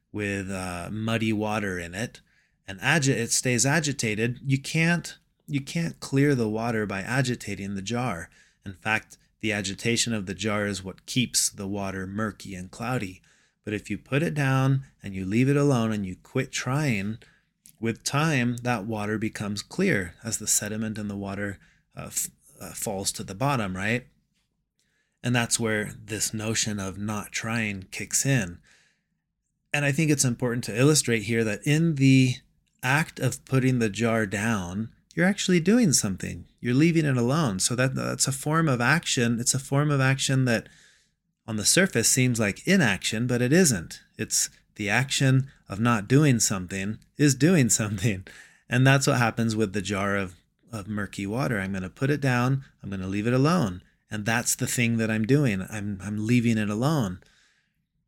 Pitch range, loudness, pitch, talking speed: 105-135 Hz, -25 LUFS, 115 Hz, 180 wpm